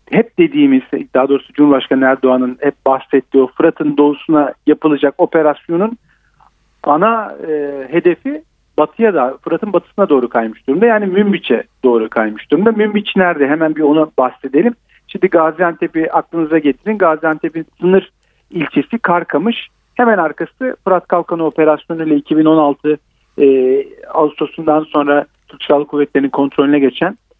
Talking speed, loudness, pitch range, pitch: 125 wpm, -14 LUFS, 145-190 Hz, 160 Hz